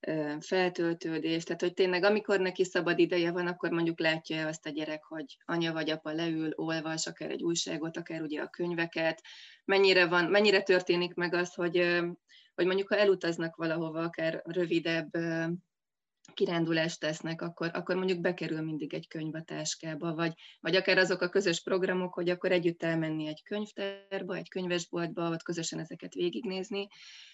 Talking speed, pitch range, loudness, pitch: 160 wpm, 160-185 Hz, -31 LUFS, 170 Hz